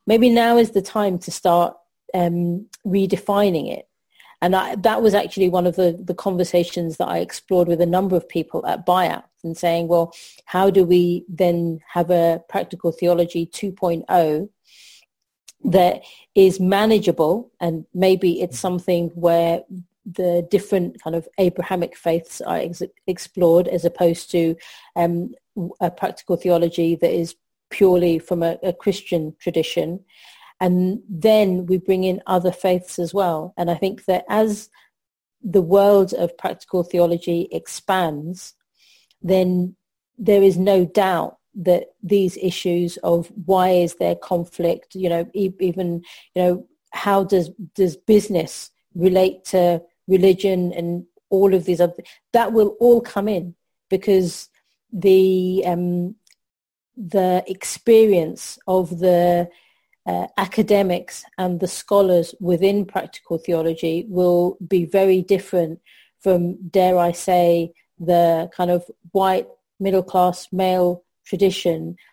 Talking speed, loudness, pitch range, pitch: 130 wpm, -19 LUFS, 175-195 Hz, 180 Hz